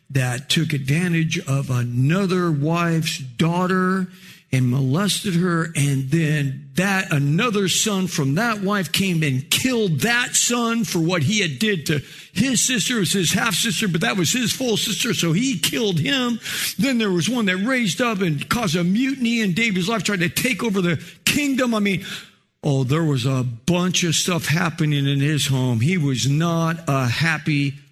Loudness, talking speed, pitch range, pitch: -20 LUFS, 180 wpm, 150-205 Hz, 175 Hz